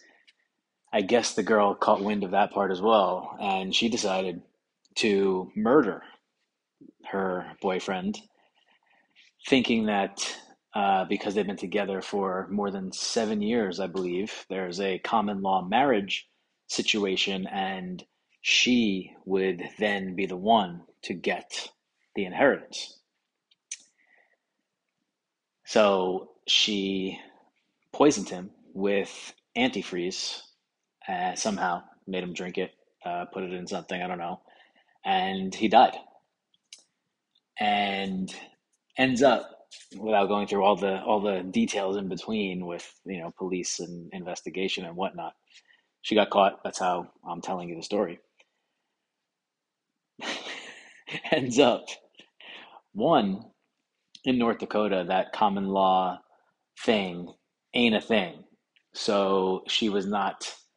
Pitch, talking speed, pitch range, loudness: 95 Hz, 120 wpm, 95-105 Hz, -27 LUFS